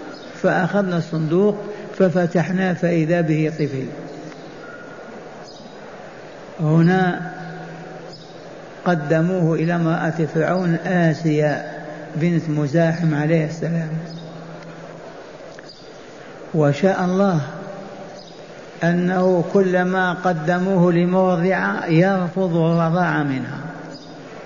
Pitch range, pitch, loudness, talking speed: 160-185 Hz, 175 Hz, -19 LUFS, 60 wpm